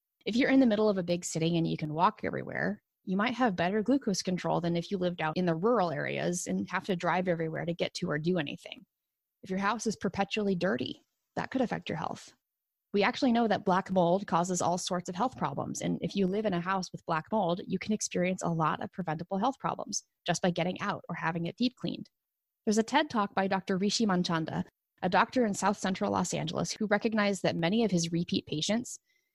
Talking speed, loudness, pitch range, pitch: 235 wpm, -31 LUFS, 170-215 Hz, 190 Hz